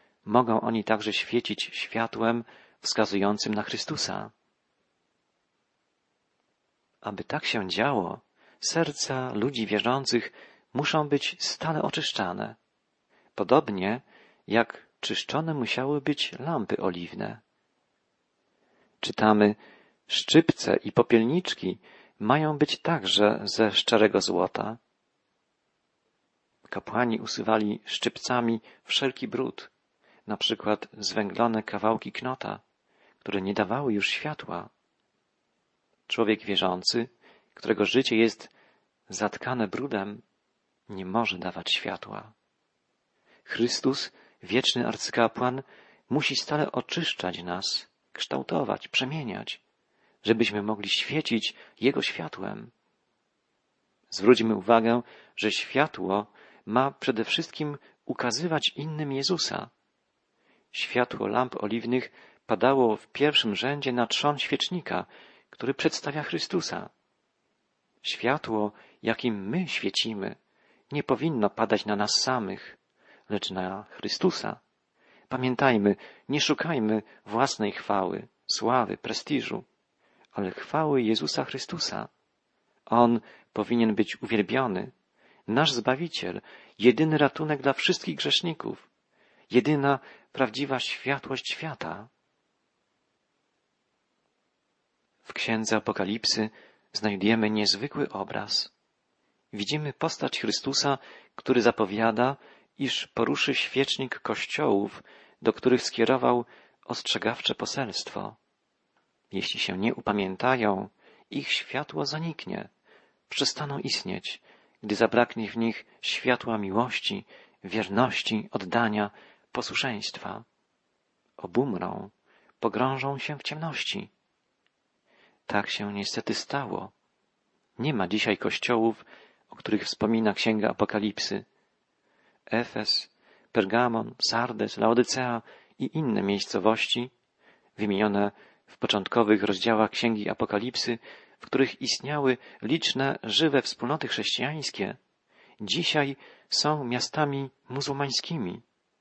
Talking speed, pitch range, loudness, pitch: 90 wpm, 105-135 Hz, -27 LUFS, 115 Hz